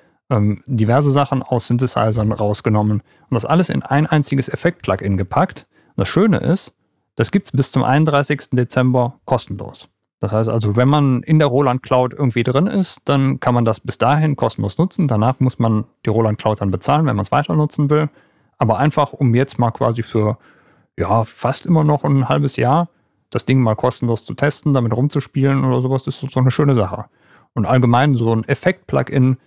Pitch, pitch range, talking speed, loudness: 130 Hz, 115-145 Hz, 195 wpm, -17 LUFS